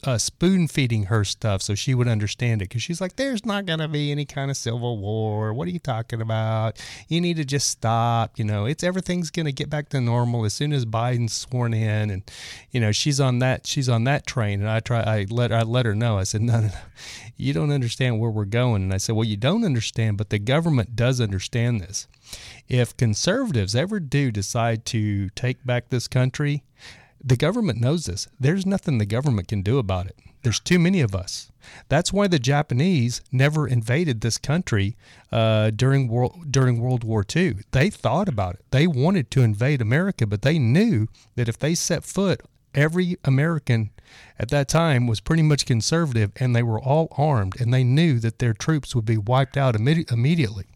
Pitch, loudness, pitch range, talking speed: 125 Hz, -22 LUFS, 110-145 Hz, 210 wpm